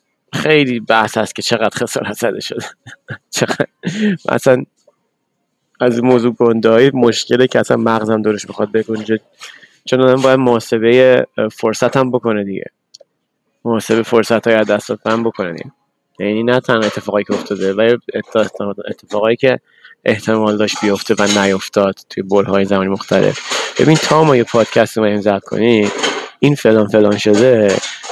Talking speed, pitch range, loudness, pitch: 135 wpm, 105-125 Hz, -14 LUFS, 110 Hz